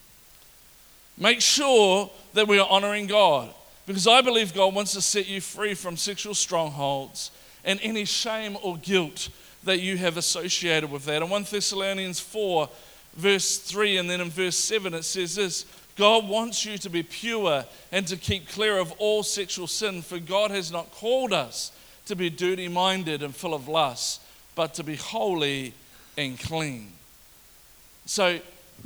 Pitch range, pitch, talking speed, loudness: 170-205 Hz, 190 Hz, 160 wpm, -25 LUFS